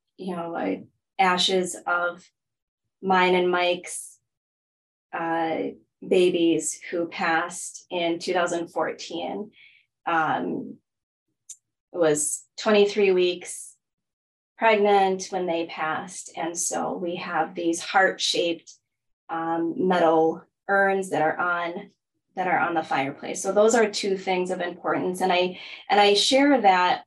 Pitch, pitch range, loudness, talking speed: 175 Hz, 165-190 Hz, -24 LUFS, 120 wpm